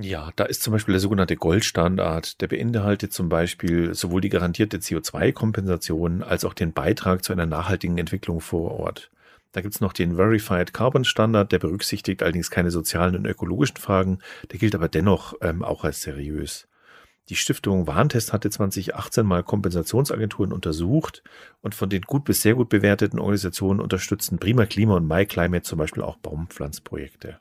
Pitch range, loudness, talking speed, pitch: 85-105 Hz, -23 LUFS, 165 wpm, 95 Hz